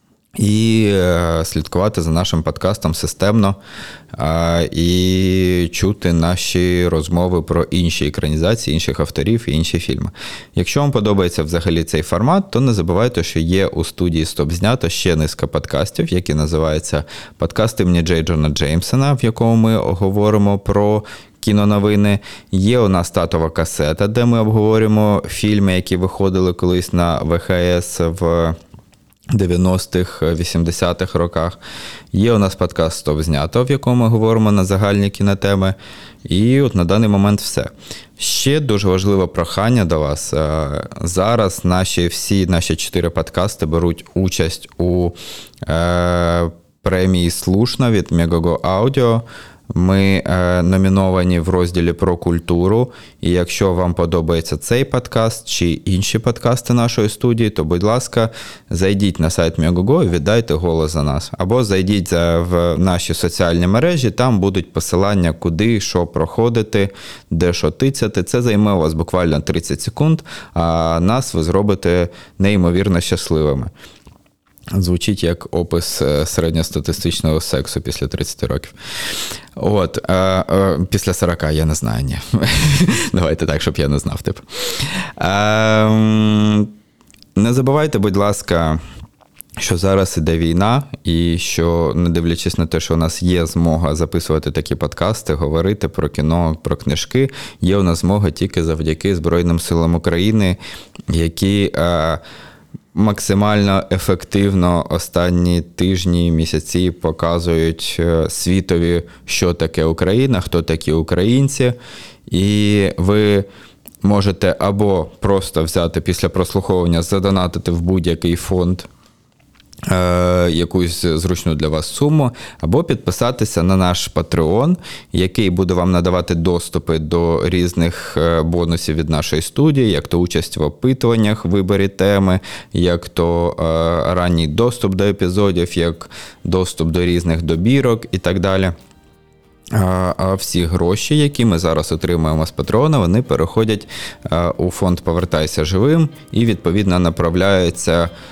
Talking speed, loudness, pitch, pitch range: 125 wpm, -16 LUFS, 90 Hz, 85-100 Hz